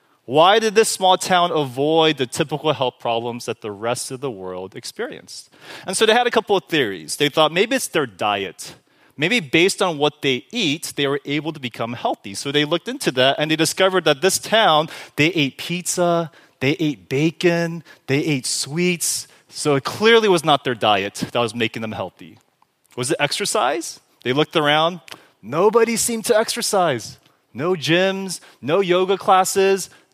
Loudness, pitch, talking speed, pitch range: -19 LUFS, 155 Hz, 180 wpm, 135-185 Hz